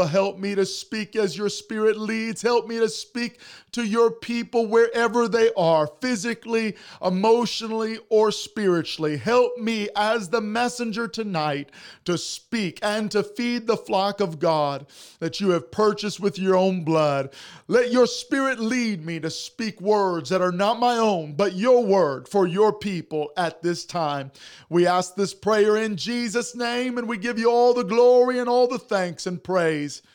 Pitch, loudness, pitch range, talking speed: 215 Hz, -23 LUFS, 180-235 Hz, 175 wpm